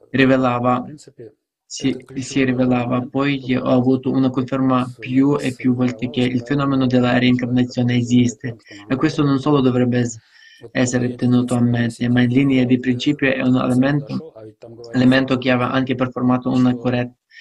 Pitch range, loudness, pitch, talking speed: 125-130 Hz, -18 LUFS, 125 Hz, 150 wpm